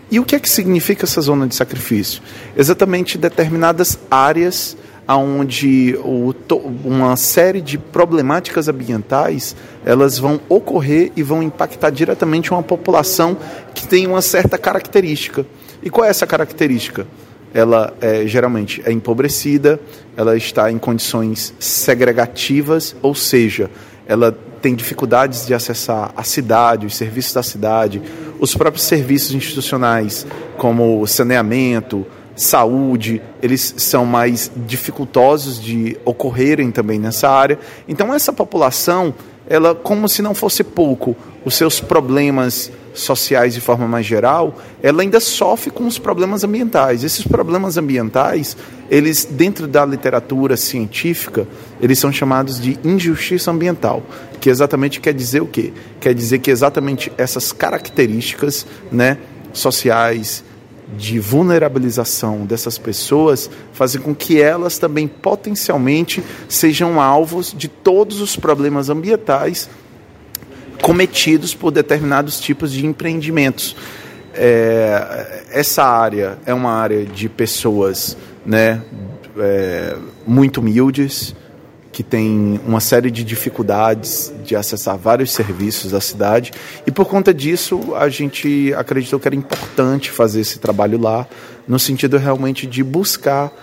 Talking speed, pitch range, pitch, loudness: 125 wpm, 115-155 Hz, 135 Hz, -15 LUFS